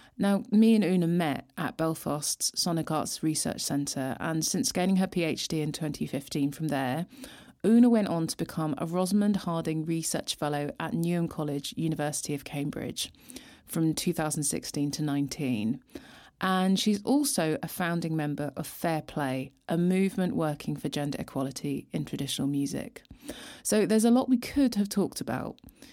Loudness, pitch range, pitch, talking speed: -29 LUFS, 145-185 Hz, 160 Hz, 155 wpm